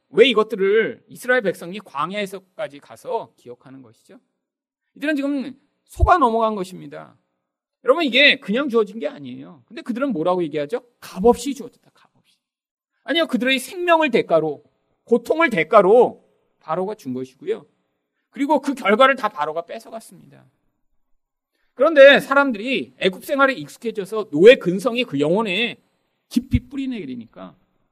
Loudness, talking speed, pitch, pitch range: -18 LUFS, 335 characters per minute, 230 Hz, 175-275 Hz